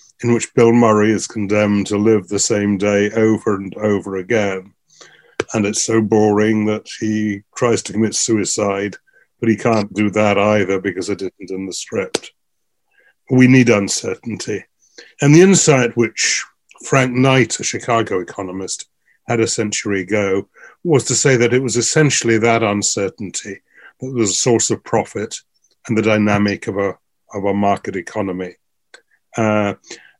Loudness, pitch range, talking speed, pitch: -16 LUFS, 100-115 Hz, 155 wpm, 105 Hz